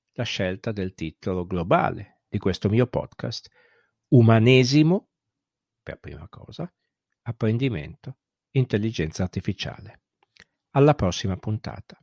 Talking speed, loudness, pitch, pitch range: 95 wpm, -23 LUFS, 110 Hz, 95-125 Hz